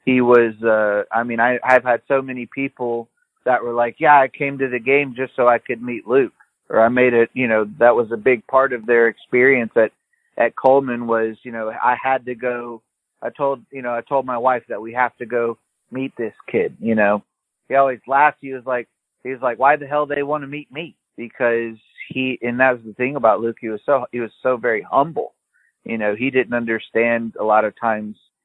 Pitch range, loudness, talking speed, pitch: 115-135 Hz, -19 LUFS, 235 wpm, 125 Hz